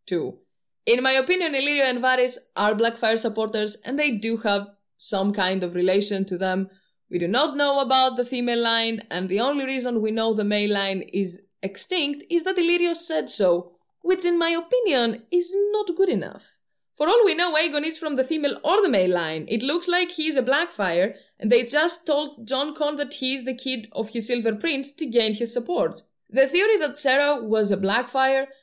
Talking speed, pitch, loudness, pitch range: 205 wpm, 255 Hz, -22 LUFS, 210-300 Hz